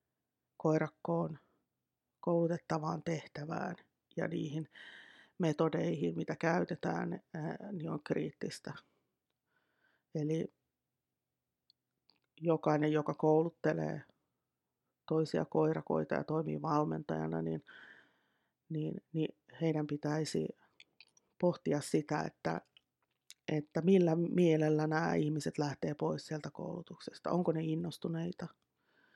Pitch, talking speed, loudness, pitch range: 155 Hz, 80 wpm, -36 LUFS, 150-170 Hz